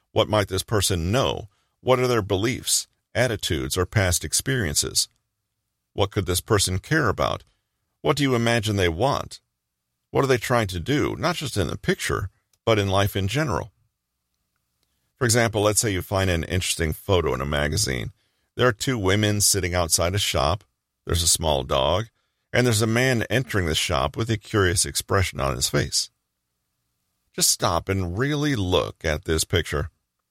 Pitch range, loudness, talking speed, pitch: 85-115 Hz, -23 LUFS, 170 wpm, 100 Hz